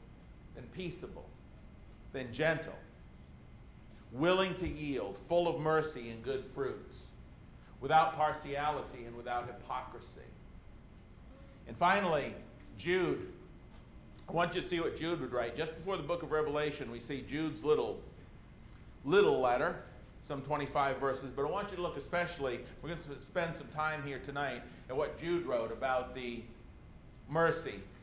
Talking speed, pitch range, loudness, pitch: 145 wpm, 125-165 Hz, -35 LUFS, 145 Hz